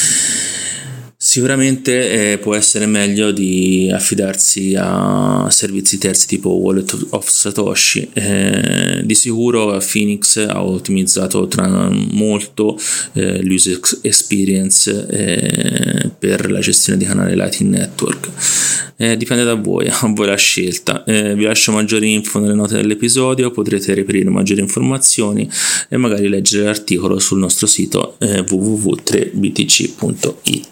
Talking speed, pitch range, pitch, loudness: 120 wpm, 95-110 Hz, 105 Hz, -13 LUFS